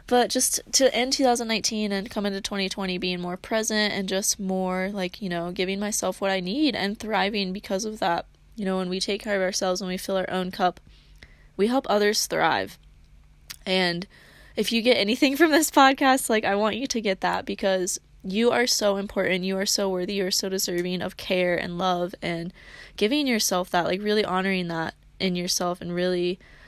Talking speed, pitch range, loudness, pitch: 200 wpm, 185-215 Hz, -24 LUFS, 195 Hz